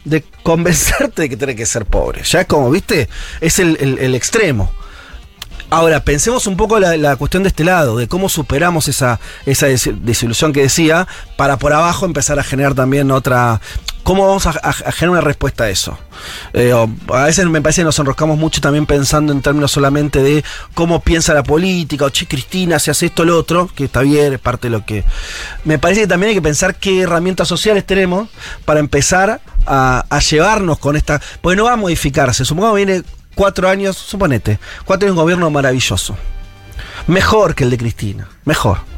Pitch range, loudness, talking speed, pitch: 130-175 Hz, -13 LUFS, 200 wpm, 150 Hz